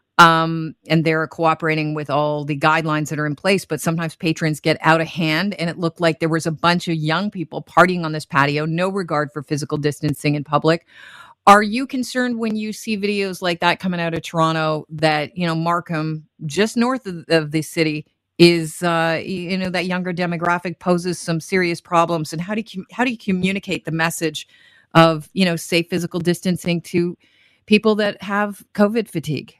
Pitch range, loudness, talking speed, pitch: 155-185 Hz, -19 LUFS, 195 wpm, 165 Hz